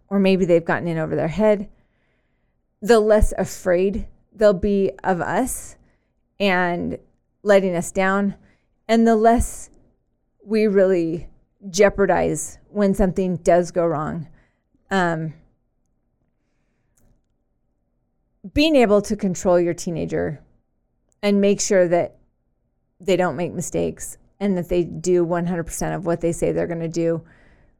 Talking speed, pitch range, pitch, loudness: 125 wpm, 170-200 Hz, 180 Hz, -20 LUFS